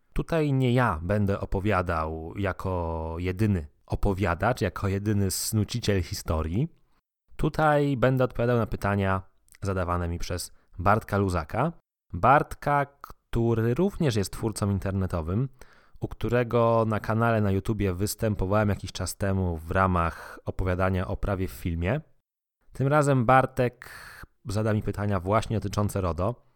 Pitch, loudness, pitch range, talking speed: 100 Hz, -27 LUFS, 95-120 Hz, 120 wpm